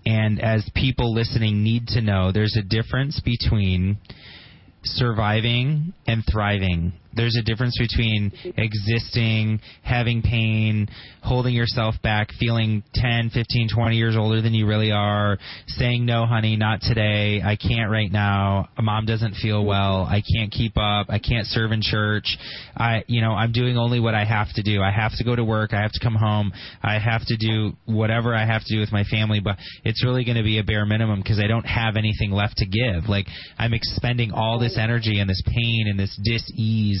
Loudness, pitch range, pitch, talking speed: -22 LUFS, 105-115 Hz, 110 Hz, 195 wpm